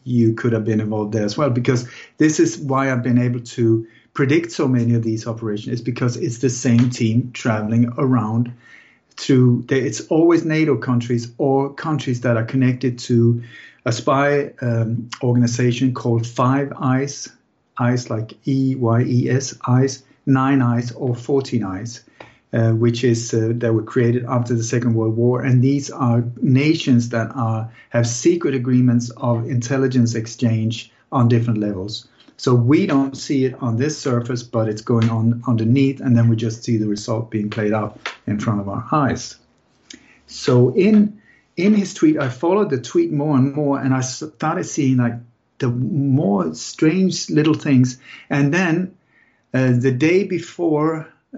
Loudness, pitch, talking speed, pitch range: -19 LUFS, 125 Hz, 165 wpm, 115-140 Hz